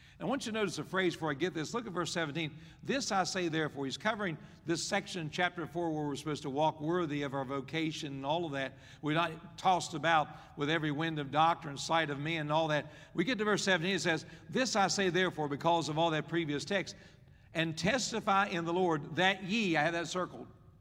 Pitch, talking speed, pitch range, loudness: 165 Hz, 235 wpm, 150-180 Hz, -33 LUFS